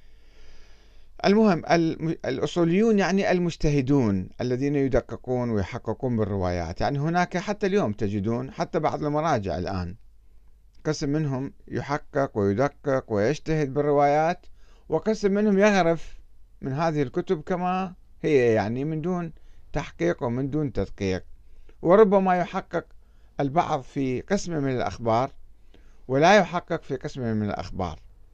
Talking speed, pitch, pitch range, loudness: 110 wpm, 145 Hz, 110-170 Hz, -25 LUFS